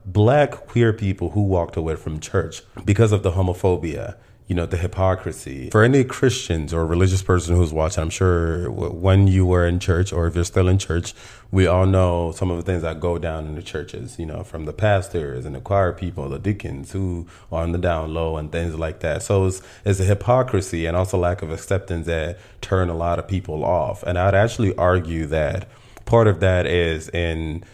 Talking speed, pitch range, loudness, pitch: 210 wpm, 85-100 Hz, -21 LUFS, 90 Hz